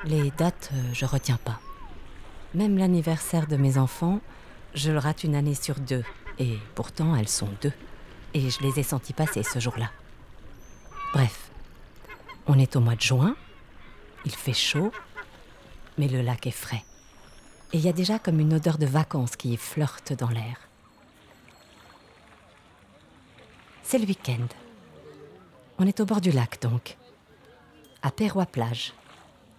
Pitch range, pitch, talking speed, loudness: 120-160 Hz, 135 Hz, 145 wpm, -27 LUFS